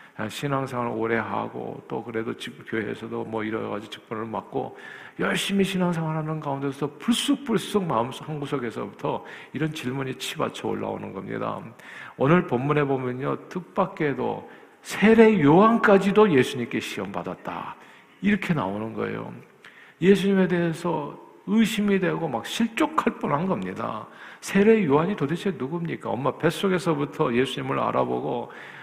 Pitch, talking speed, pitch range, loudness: 155 Hz, 330 characters per minute, 125-195 Hz, -24 LUFS